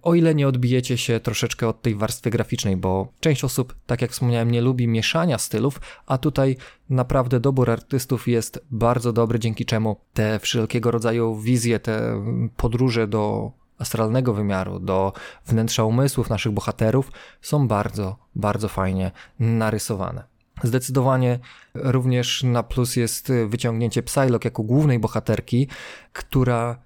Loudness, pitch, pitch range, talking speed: -22 LUFS, 120 Hz, 110-130 Hz, 135 wpm